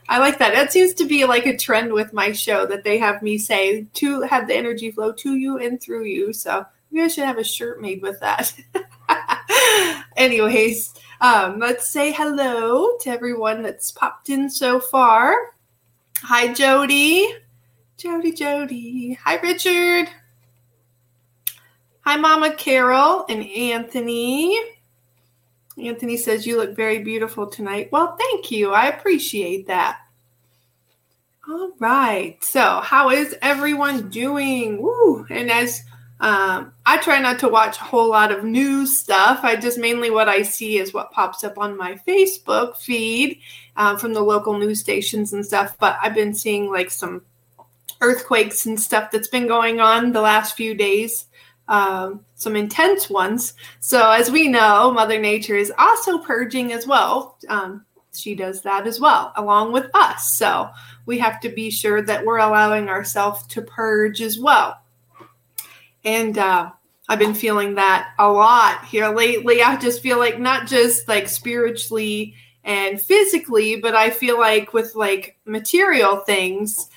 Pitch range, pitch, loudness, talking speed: 210-265 Hz, 225 Hz, -18 LUFS, 155 wpm